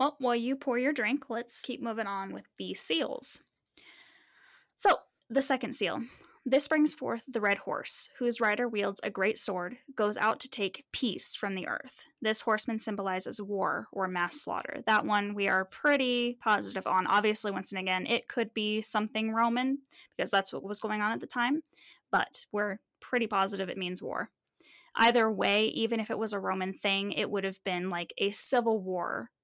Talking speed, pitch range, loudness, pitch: 190 wpm, 200-250 Hz, -30 LUFS, 220 Hz